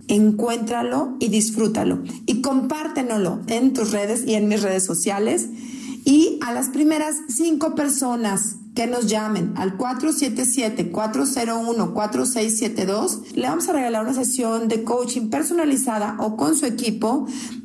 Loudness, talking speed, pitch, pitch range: -21 LUFS, 125 wpm, 240 Hz, 215-265 Hz